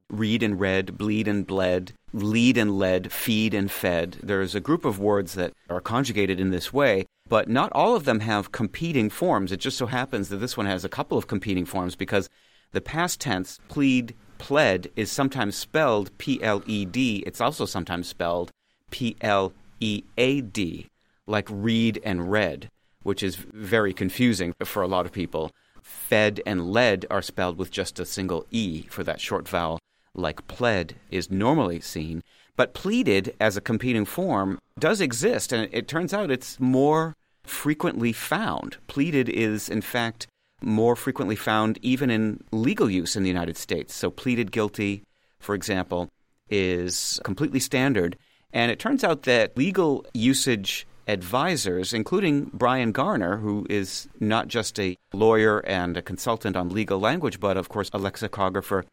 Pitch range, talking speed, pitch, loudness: 95-120 Hz, 170 wpm, 105 Hz, -25 LUFS